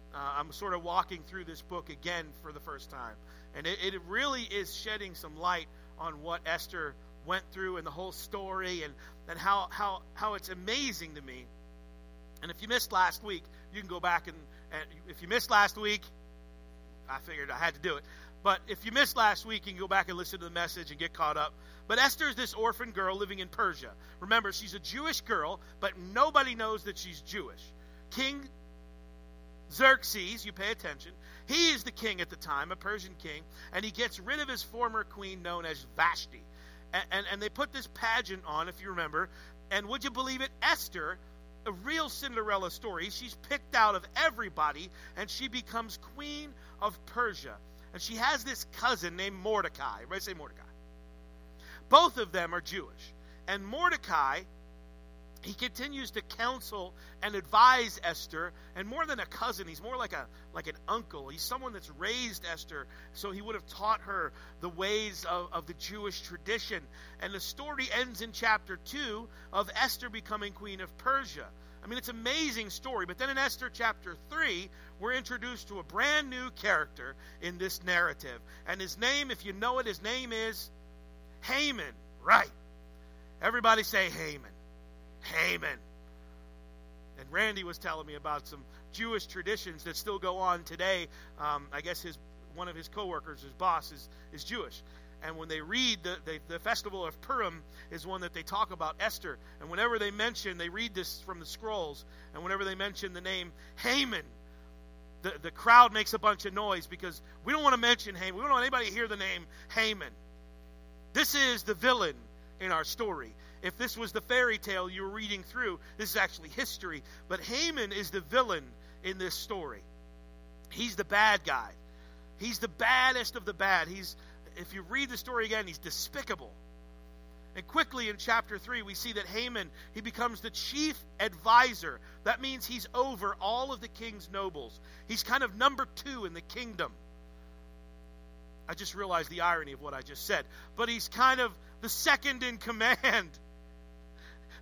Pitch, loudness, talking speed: 190 Hz, -32 LUFS, 185 wpm